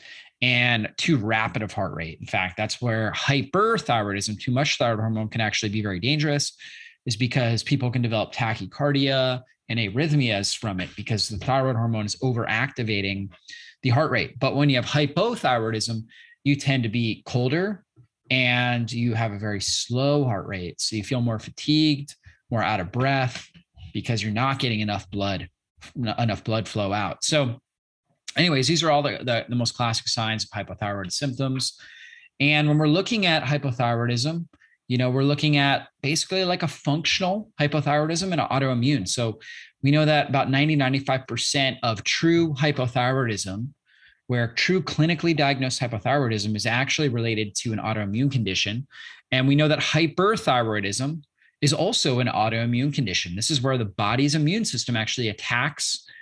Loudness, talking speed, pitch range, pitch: -23 LUFS, 160 wpm, 110-145 Hz, 125 Hz